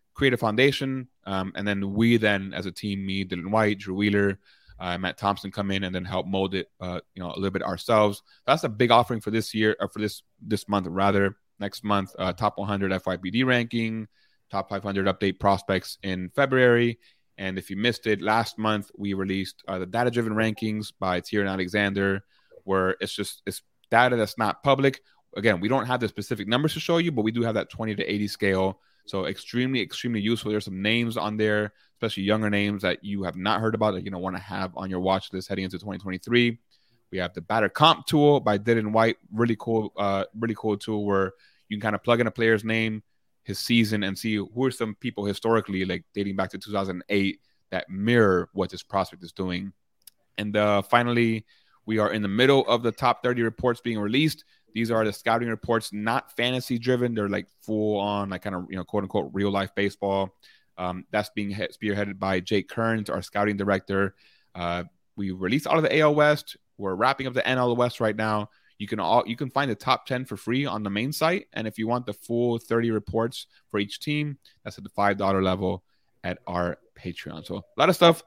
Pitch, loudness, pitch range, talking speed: 105 Hz, -26 LUFS, 95-115 Hz, 215 wpm